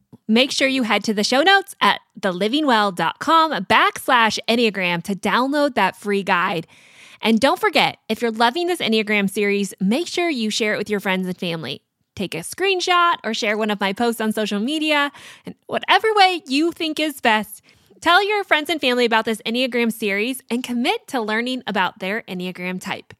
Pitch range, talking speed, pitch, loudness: 210-295 Hz, 185 wpm, 230 Hz, -19 LUFS